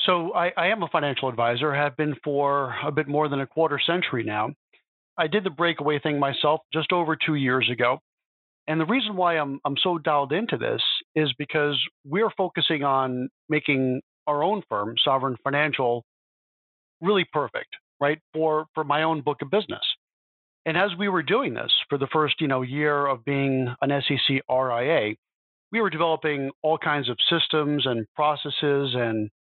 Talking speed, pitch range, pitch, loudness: 175 wpm, 135-160 Hz, 150 Hz, -24 LUFS